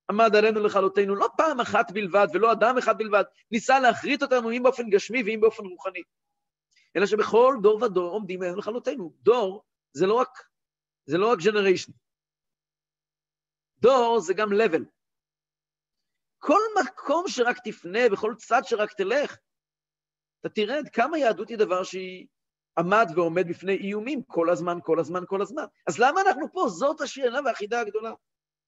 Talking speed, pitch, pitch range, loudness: 150 wpm, 215 Hz, 185-255 Hz, -24 LUFS